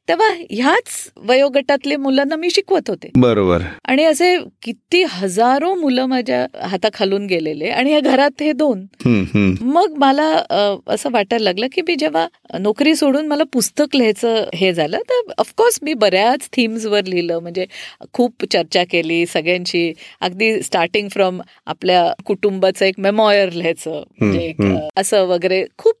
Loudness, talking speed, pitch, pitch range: -16 LUFS, 135 wpm, 215 Hz, 180-285 Hz